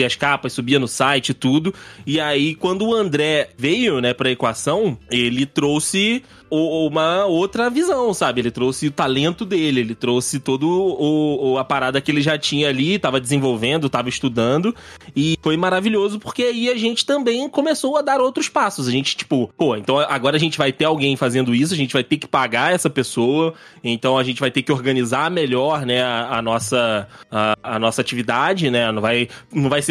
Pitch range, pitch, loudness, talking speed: 130-165 Hz, 140 Hz, -19 LUFS, 200 wpm